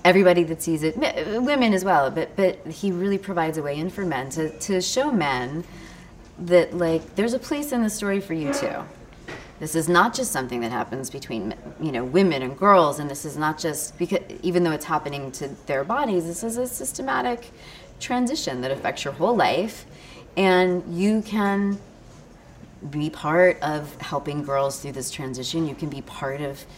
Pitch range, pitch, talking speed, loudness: 145-195 Hz, 165 Hz, 190 wpm, -24 LUFS